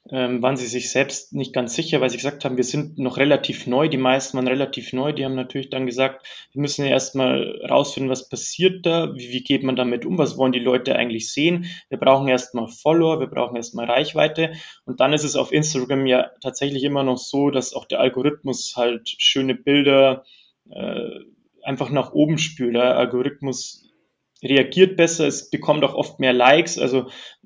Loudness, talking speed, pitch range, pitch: -20 LUFS, 190 wpm, 125-145 Hz, 135 Hz